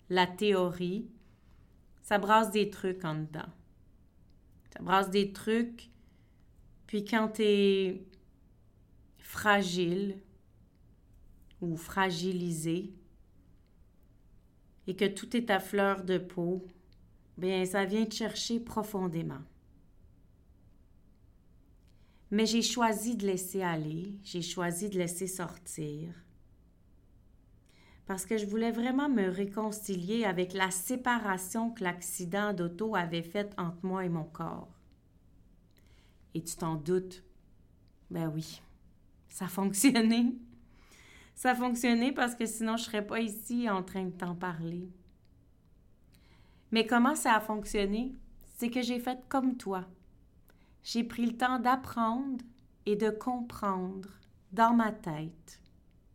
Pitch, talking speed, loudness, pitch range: 190 Hz, 120 wpm, -32 LUFS, 170-220 Hz